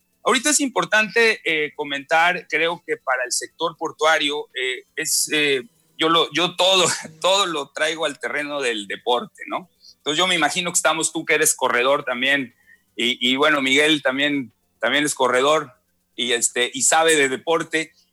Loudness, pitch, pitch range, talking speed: -19 LUFS, 155 Hz, 140-170 Hz, 170 wpm